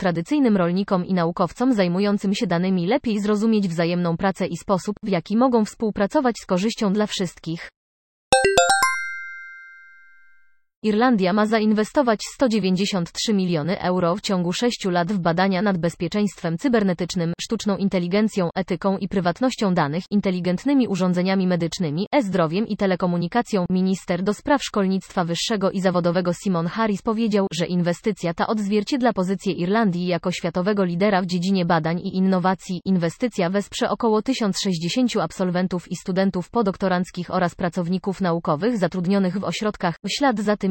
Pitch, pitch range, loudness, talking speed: 190 Hz, 175-210 Hz, -22 LUFS, 130 wpm